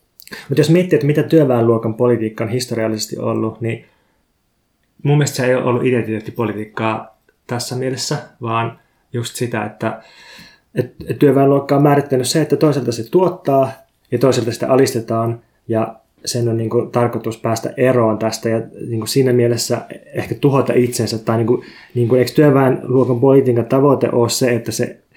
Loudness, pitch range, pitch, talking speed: -17 LUFS, 115-135 Hz, 120 Hz, 160 wpm